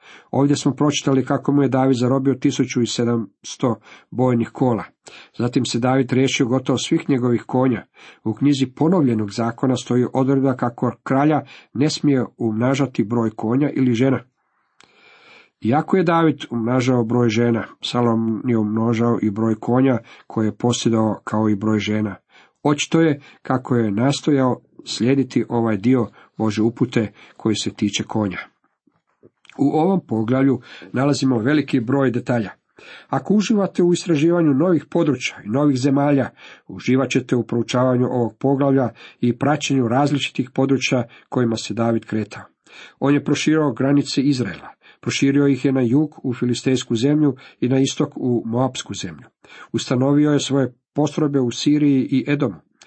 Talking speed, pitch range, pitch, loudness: 140 wpm, 120-140 Hz, 130 Hz, -19 LUFS